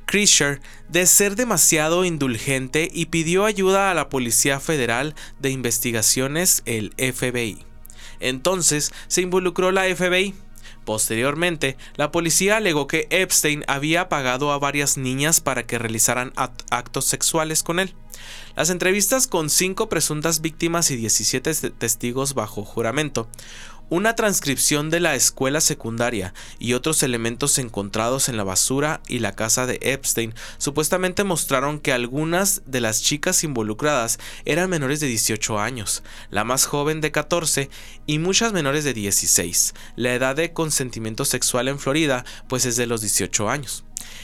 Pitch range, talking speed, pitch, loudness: 120-165 Hz, 140 wpm, 140 Hz, -20 LUFS